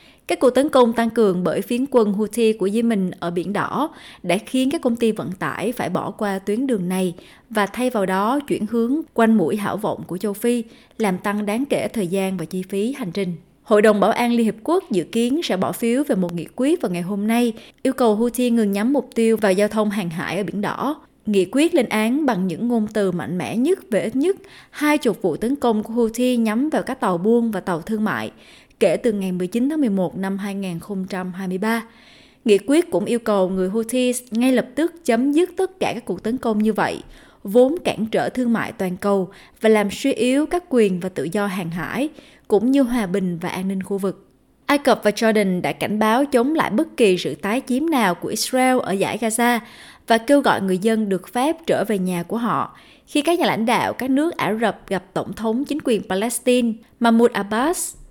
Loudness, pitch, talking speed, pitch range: -20 LUFS, 225 Hz, 230 wpm, 195-250 Hz